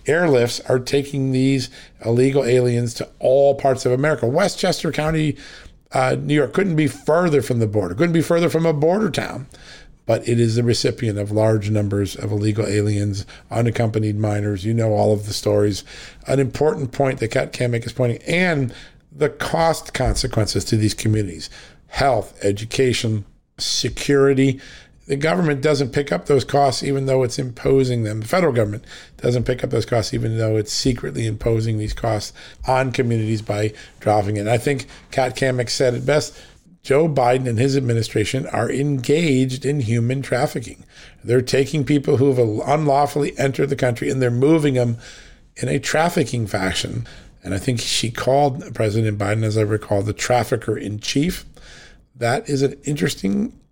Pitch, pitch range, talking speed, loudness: 125 Hz, 110-140 Hz, 170 wpm, -20 LUFS